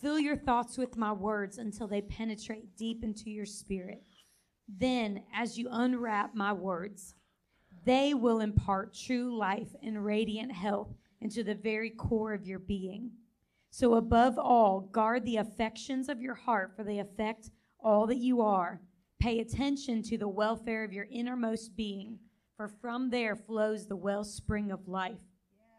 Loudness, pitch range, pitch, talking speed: -33 LUFS, 205-235 Hz, 220 Hz, 155 wpm